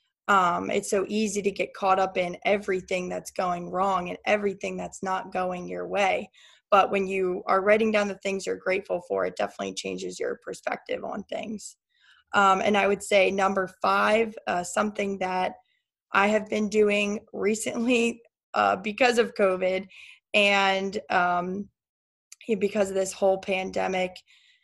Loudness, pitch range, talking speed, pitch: -26 LUFS, 190-210 Hz, 155 wpm, 195 Hz